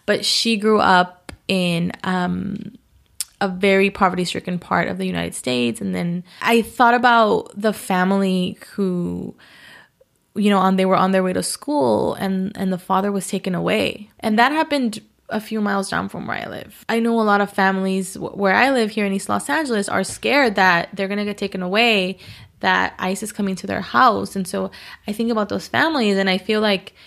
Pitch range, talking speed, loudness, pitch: 185-220 Hz, 205 wpm, -19 LUFS, 195 Hz